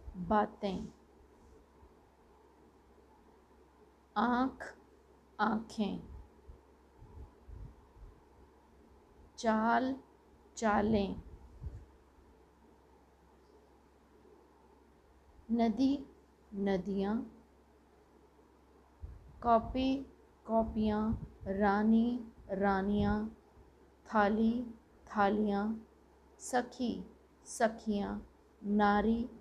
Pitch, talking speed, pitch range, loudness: 220 Hz, 35 wpm, 205-235 Hz, -34 LUFS